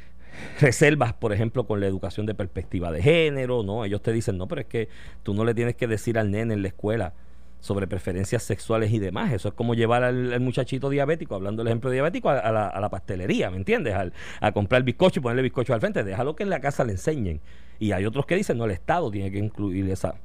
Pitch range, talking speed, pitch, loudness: 100-125 Hz, 250 wpm, 110 Hz, -25 LUFS